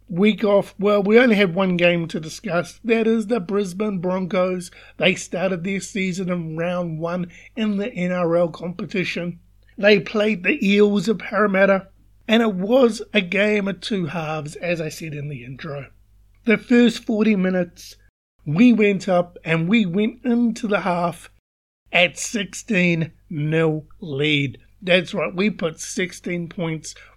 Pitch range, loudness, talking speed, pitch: 170-210 Hz, -20 LUFS, 150 wpm, 185 Hz